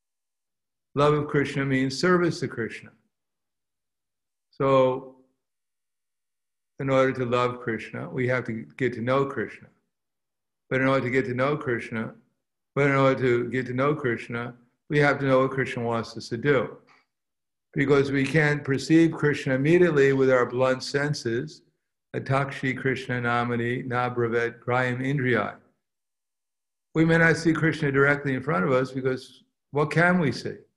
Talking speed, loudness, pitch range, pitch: 150 wpm, -24 LUFS, 125-145 Hz, 130 Hz